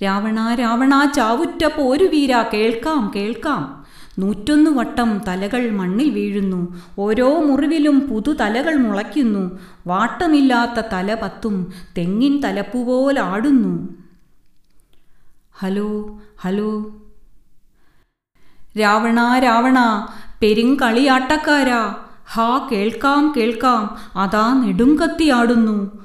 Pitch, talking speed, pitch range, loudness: 230 Hz, 70 wpm, 205-265 Hz, -17 LUFS